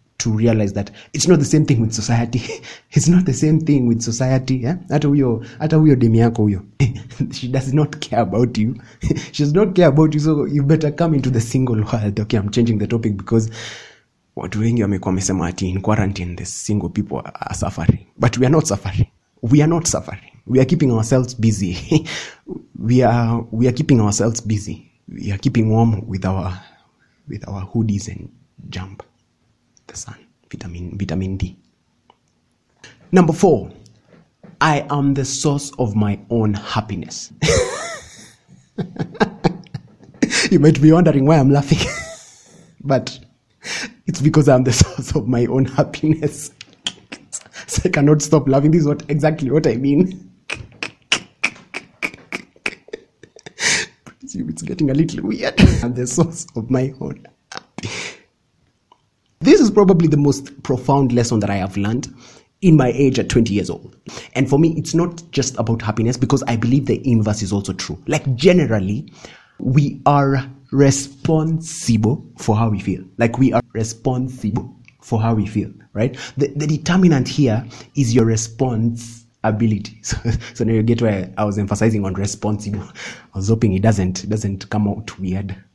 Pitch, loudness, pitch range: 120 Hz, -18 LUFS, 110-150 Hz